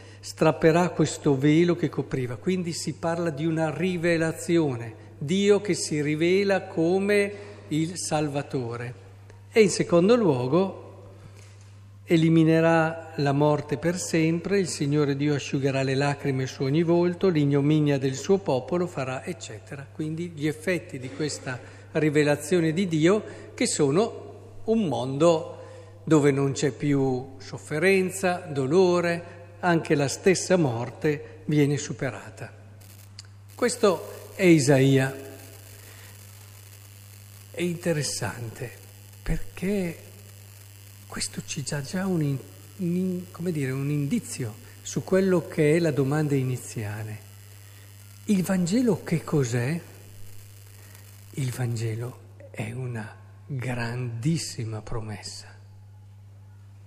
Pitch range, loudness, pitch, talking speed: 105-165 Hz, -25 LUFS, 140 Hz, 105 wpm